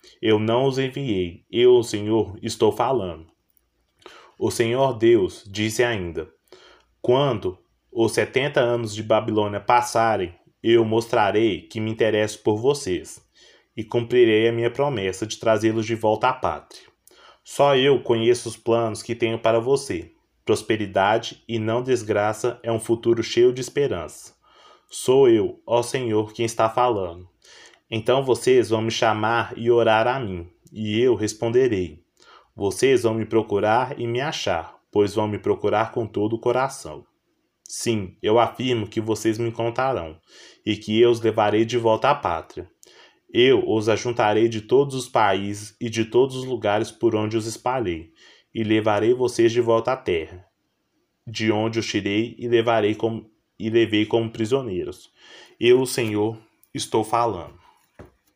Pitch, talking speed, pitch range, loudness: 115 Hz, 150 wpm, 110-125 Hz, -22 LUFS